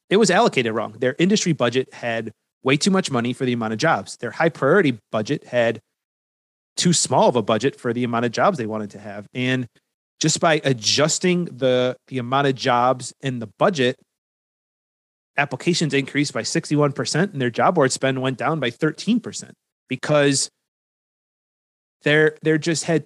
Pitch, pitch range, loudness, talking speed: 135 Hz, 120-155 Hz, -20 LUFS, 170 wpm